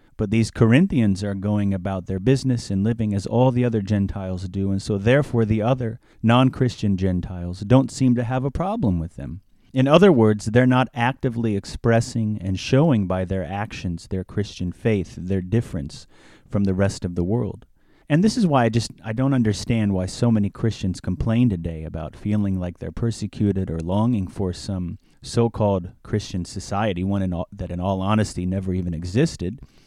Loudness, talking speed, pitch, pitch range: -22 LUFS, 185 wpm, 105 Hz, 95-120 Hz